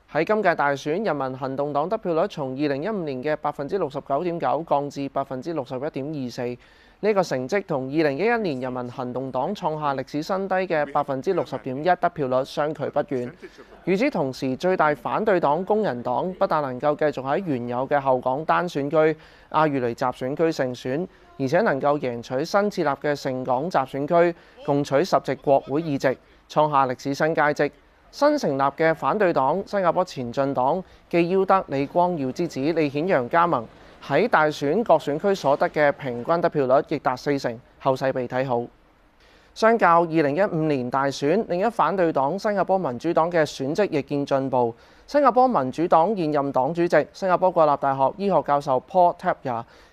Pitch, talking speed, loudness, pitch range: 145 Hz, 300 characters per minute, -23 LUFS, 135-170 Hz